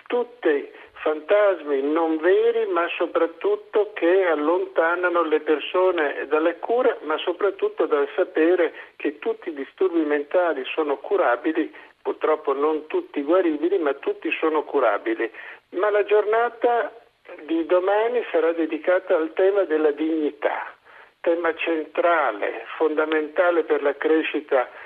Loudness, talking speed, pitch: -22 LUFS, 115 wpm, 180 Hz